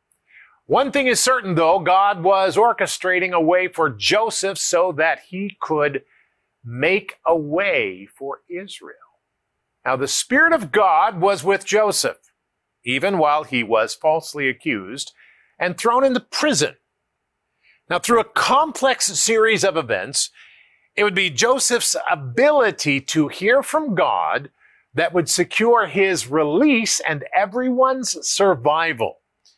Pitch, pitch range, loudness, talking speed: 195 Hz, 160-235 Hz, -18 LUFS, 130 wpm